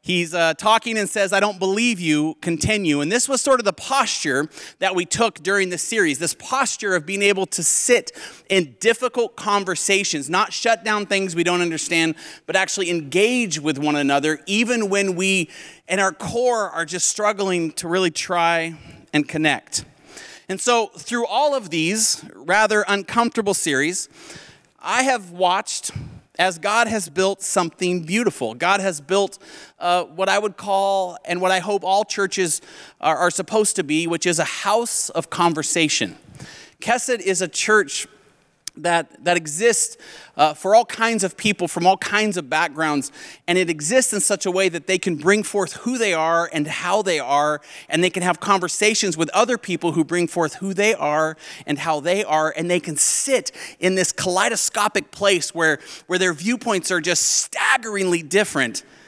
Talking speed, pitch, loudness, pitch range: 175 wpm, 185 Hz, -20 LUFS, 170-210 Hz